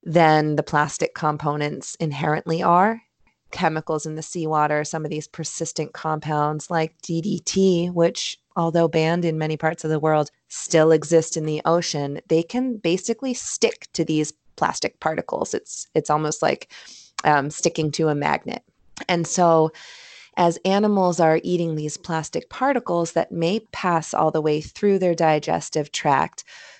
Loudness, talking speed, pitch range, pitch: -22 LUFS, 150 wpm, 155-175 Hz, 160 Hz